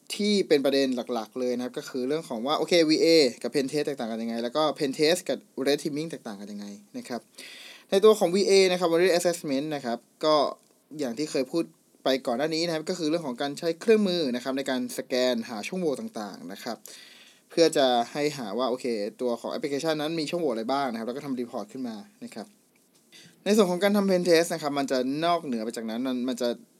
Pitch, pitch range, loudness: 150 Hz, 130-180 Hz, -26 LUFS